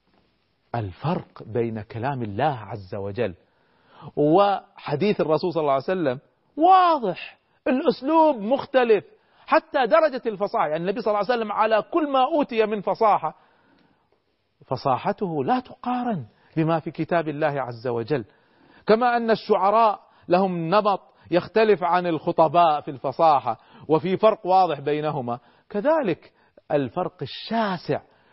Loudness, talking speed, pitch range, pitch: -23 LUFS, 120 wpm, 145-225 Hz, 180 Hz